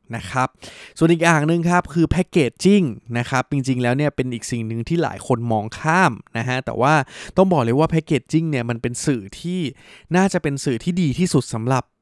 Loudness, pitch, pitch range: -20 LUFS, 140 Hz, 120-170 Hz